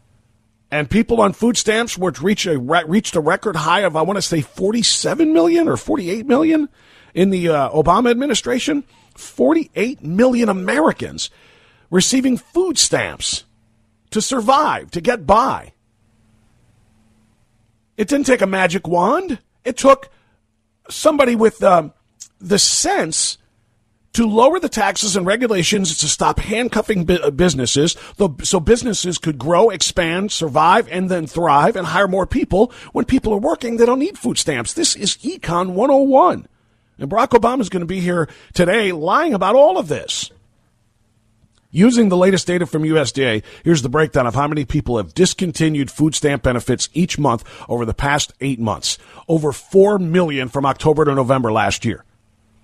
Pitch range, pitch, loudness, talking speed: 135-225 Hz, 175 Hz, -16 LUFS, 155 wpm